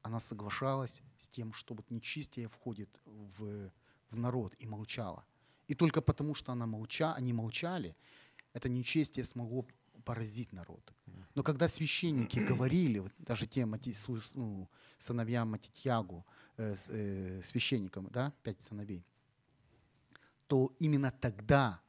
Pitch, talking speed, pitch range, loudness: 120 Hz, 120 wpm, 105-130 Hz, -37 LUFS